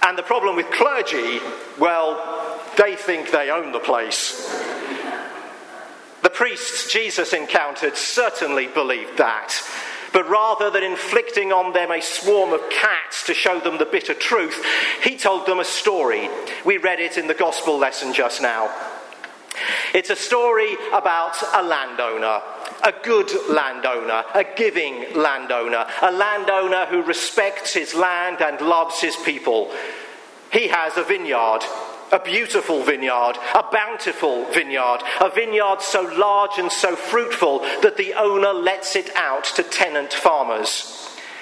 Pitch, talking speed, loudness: 195 Hz, 140 wpm, -20 LUFS